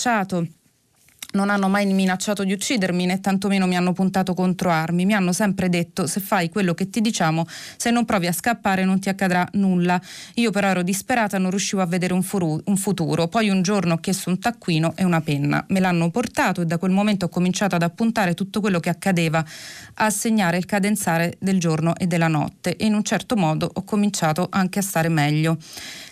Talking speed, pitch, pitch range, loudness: 200 wpm, 185 Hz, 170-205 Hz, -21 LUFS